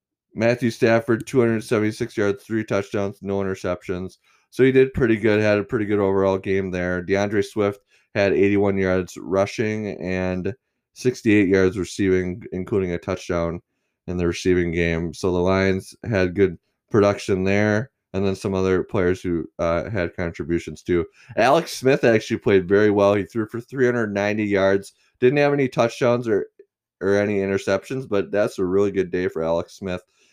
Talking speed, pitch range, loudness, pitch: 170 wpm, 95-110 Hz, -21 LUFS, 100 Hz